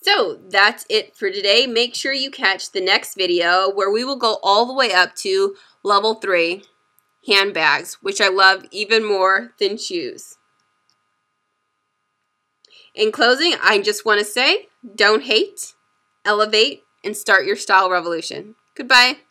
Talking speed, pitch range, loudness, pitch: 145 wpm, 175-255 Hz, -17 LUFS, 205 Hz